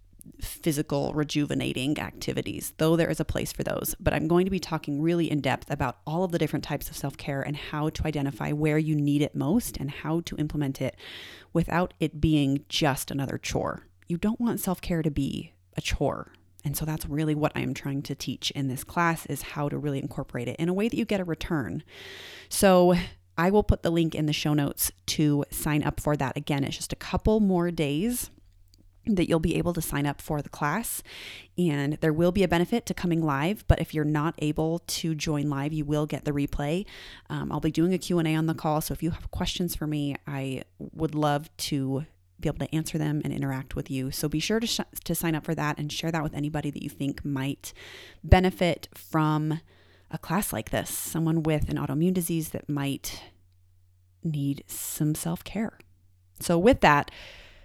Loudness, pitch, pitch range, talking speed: -28 LUFS, 150 Hz, 140-165 Hz, 215 wpm